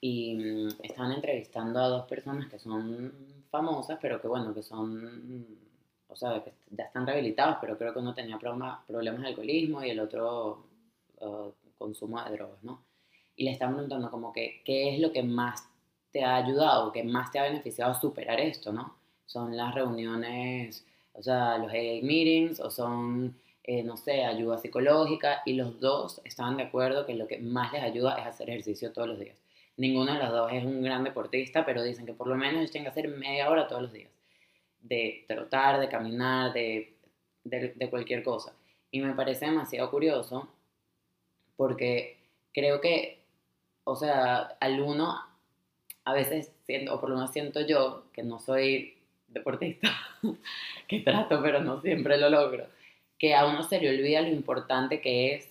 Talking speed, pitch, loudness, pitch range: 180 wpm, 125 Hz, -30 LUFS, 115-140 Hz